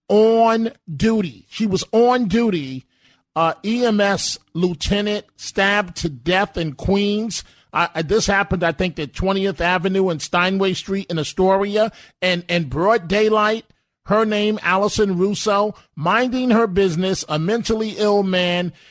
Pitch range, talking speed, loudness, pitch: 175-215 Hz, 135 wpm, -19 LUFS, 195 Hz